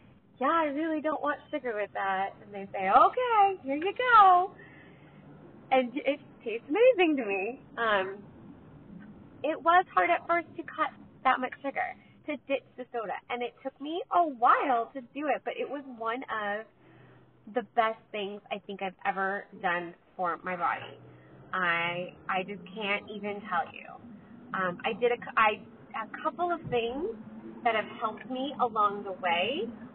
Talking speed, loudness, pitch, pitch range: 170 wpm, -29 LUFS, 240 Hz, 205-300 Hz